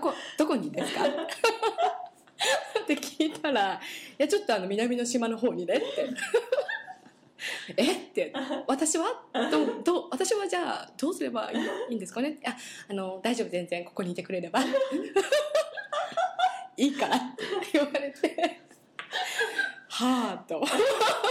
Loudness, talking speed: -29 LUFS, 250 characters per minute